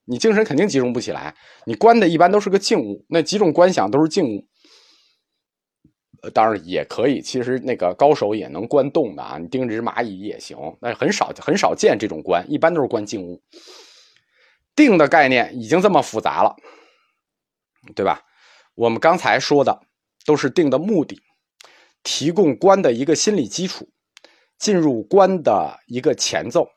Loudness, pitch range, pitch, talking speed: -18 LUFS, 130-215 Hz, 175 Hz, 255 characters per minute